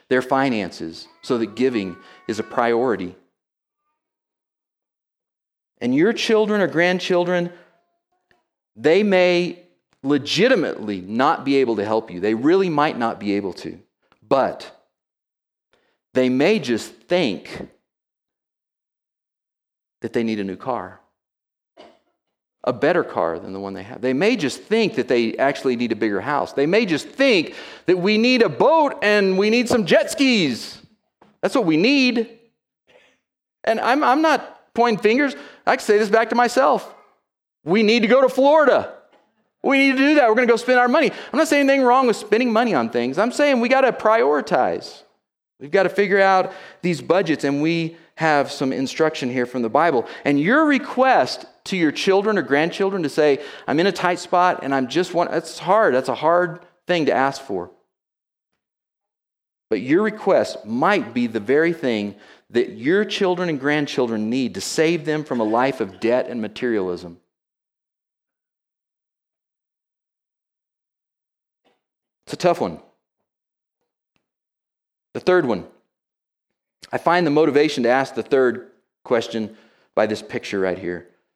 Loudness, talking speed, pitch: -19 LUFS, 160 wpm, 175 Hz